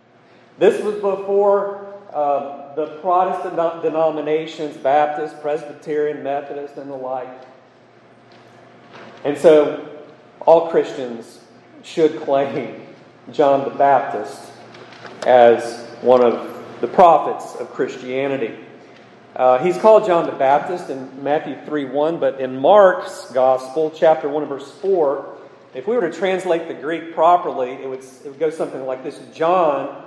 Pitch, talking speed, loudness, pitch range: 150 Hz, 125 wpm, -18 LUFS, 135-170 Hz